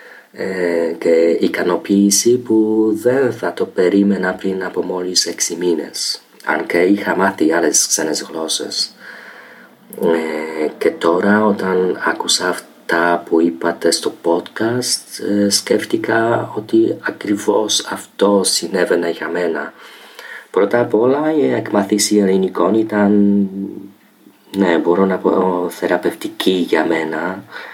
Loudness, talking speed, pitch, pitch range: -16 LUFS, 105 wpm, 100 Hz, 90-110 Hz